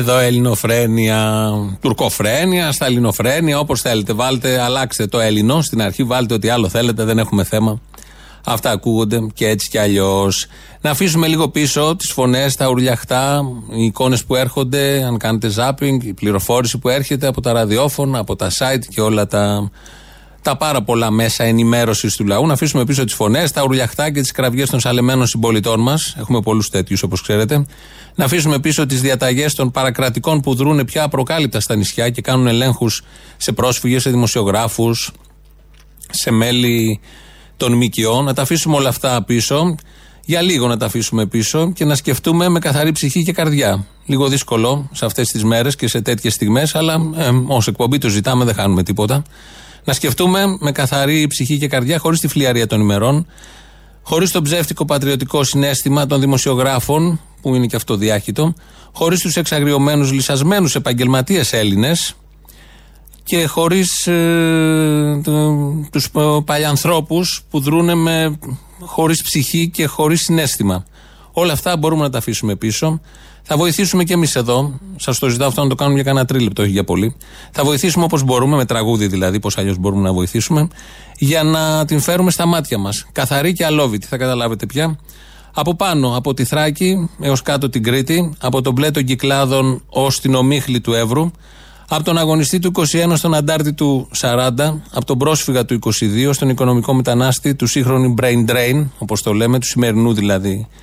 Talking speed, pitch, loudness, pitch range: 170 wpm, 130 Hz, -15 LUFS, 115-150 Hz